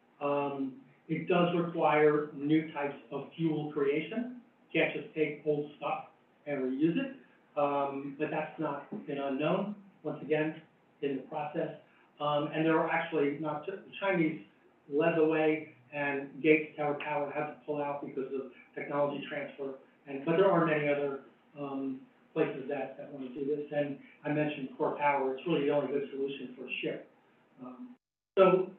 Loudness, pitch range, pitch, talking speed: -33 LUFS, 140-155 Hz, 150 Hz, 170 wpm